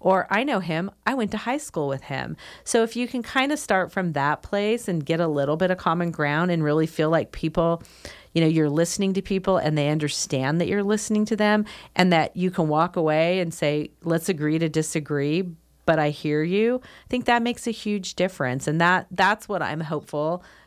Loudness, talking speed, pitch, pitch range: -24 LUFS, 225 wpm, 175 Hz, 155-205 Hz